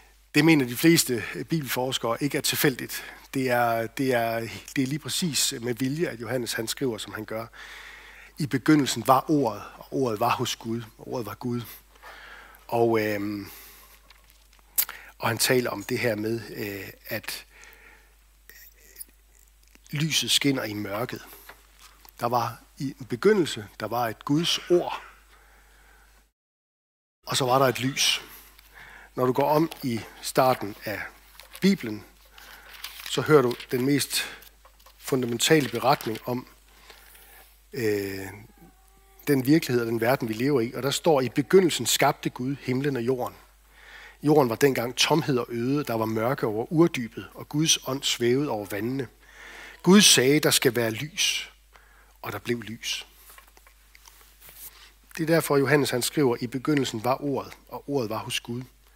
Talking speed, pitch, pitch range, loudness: 150 wpm, 130 Hz, 115-150 Hz, -25 LUFS